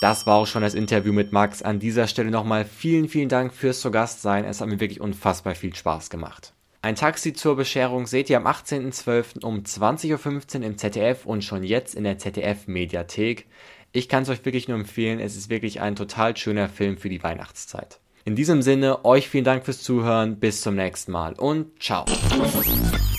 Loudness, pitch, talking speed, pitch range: -23 LUFS, 110 Hz, 200 wpm, 100-130 Hz